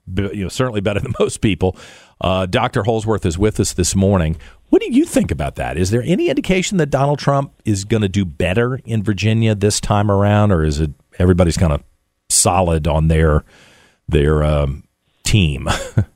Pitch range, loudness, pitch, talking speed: 80-115 Hz, -17 LUFS, 100 Hz, 185 wpm